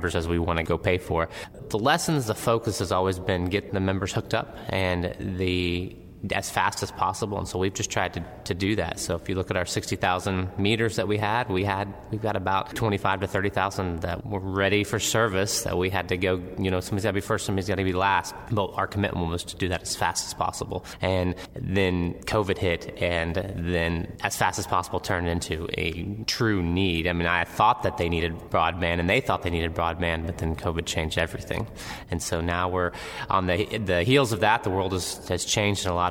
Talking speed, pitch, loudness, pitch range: 230 wpm, 95 Hz, -26 LUFS, 85-100 Hz